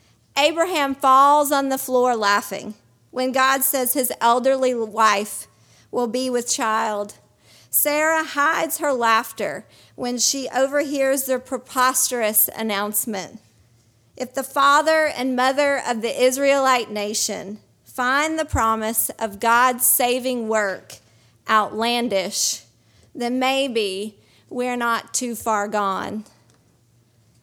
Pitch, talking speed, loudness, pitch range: 240 Hz, 110 wpm, -20 LUFS, 210-265 Hz